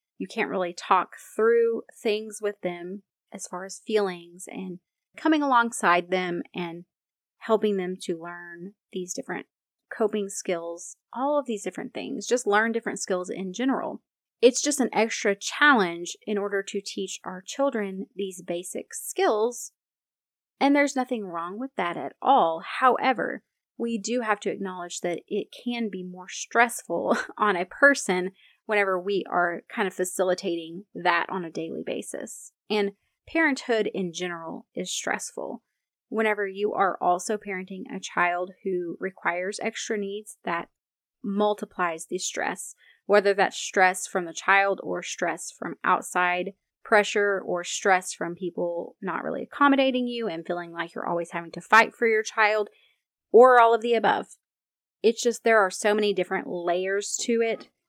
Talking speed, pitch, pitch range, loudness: 155 wpm, 200 Hz, 180-230 Hz, -25 LUFS